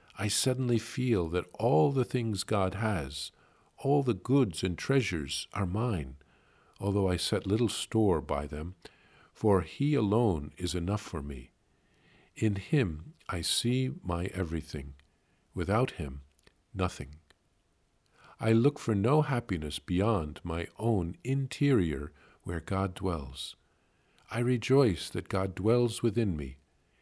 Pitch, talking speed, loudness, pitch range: 95 Hz, 130 wpm, -31 LUFS, 80-120 Hz